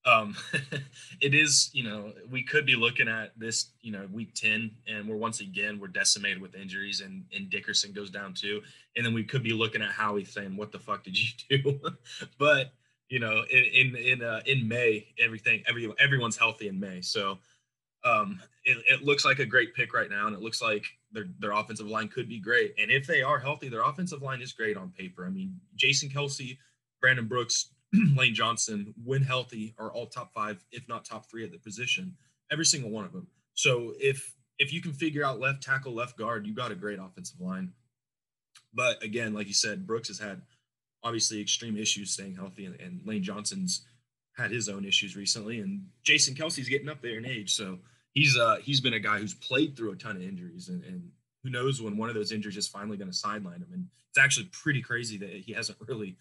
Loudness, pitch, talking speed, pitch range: -28 LUFS, 125 Hz, 215 wpm, 110-145 Hz